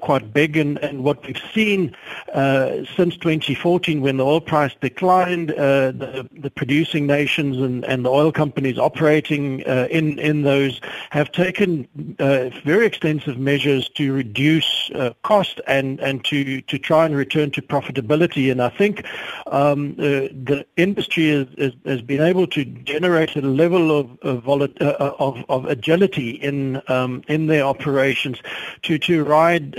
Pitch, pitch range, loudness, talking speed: 145 Hz, 135-160 Hz, -19 LUFS, 160 wpm